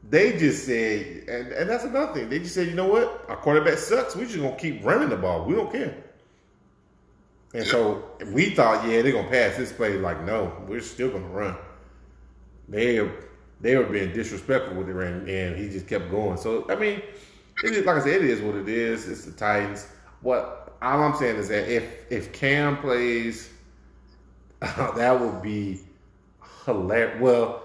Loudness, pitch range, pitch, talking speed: -25 LUFS, 95-130 Hz, 110 Hz, 190 wpm